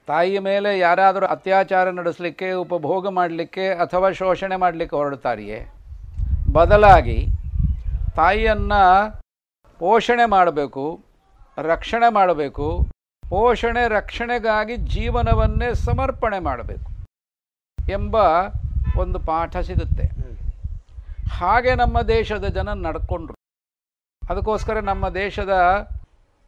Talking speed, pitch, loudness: 75 wpm, 170 Hz, -20 LUFS